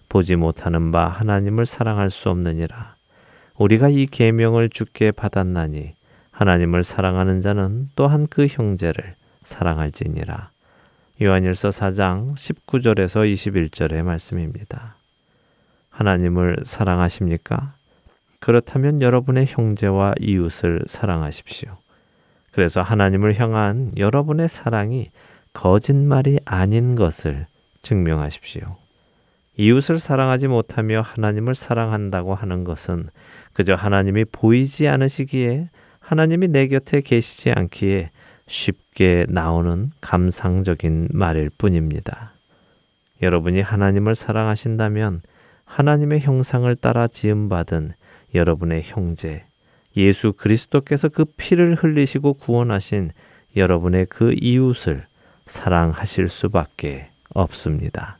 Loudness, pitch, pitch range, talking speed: -19 LUFS, 105 Hz, 90-125 Hz, 270 characters per minute